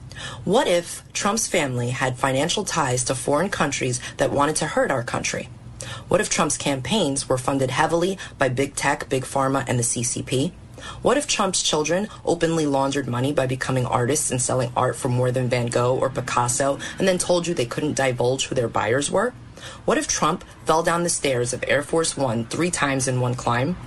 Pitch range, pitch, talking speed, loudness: 125-160 Hz, 135 Hz, 195 wpm, -22 LUFS